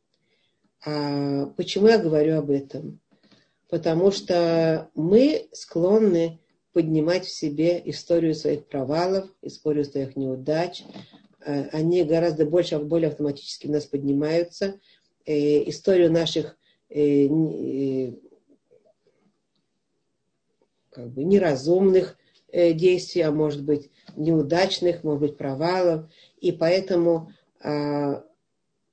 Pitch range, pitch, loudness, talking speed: 150-175 Hz, 165 Hz, -23 LUFS, 85 wpm